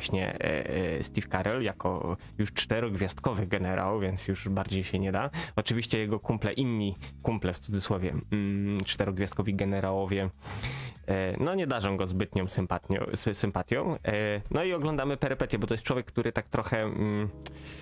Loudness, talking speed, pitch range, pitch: -31 LUFS, 130 wpm, 95-115 Hz, 105 Hz